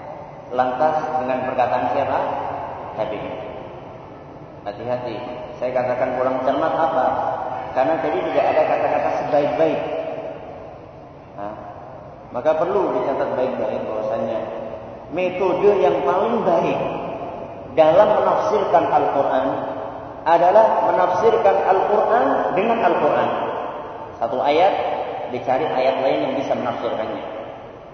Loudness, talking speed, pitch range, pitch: -20 LUFS, 95 wpm, 125-160 Hz, 135 Hz